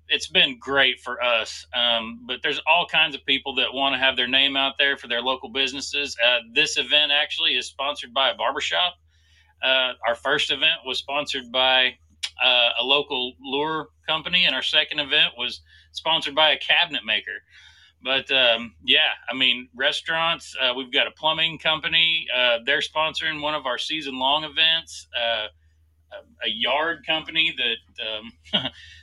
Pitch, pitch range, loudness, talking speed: 135 Hz, 120-155 Hz, -21 LUFS, 170 wpm